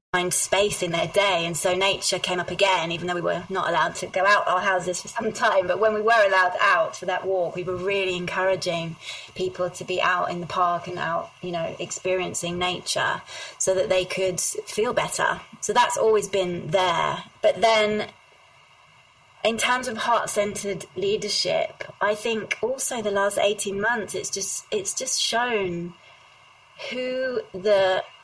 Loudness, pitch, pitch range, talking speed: -23 LUFS, 195 Hz, 180-215 Hz, 180 wpm